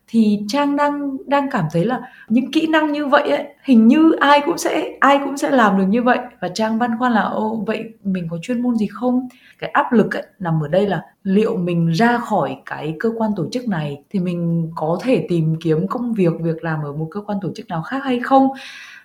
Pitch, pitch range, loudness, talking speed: 225 Hz, 180-265 Hz, -18 LUFS, 240 wpm